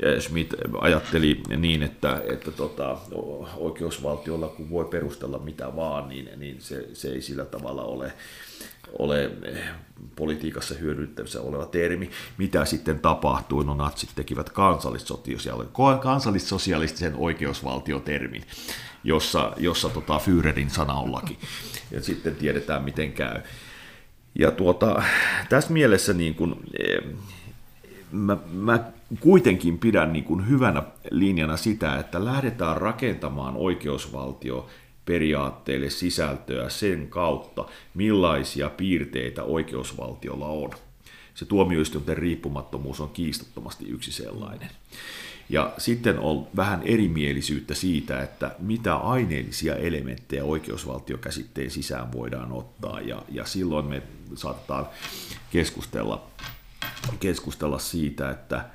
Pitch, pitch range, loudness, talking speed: 75 Hz, 70-90 Hz, -26 LUFS, 105 wpm